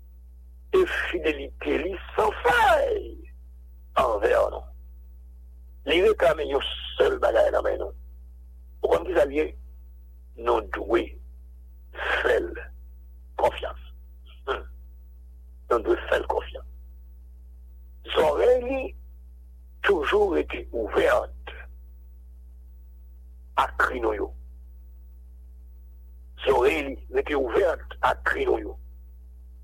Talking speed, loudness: 75 wpm, -25 LUFS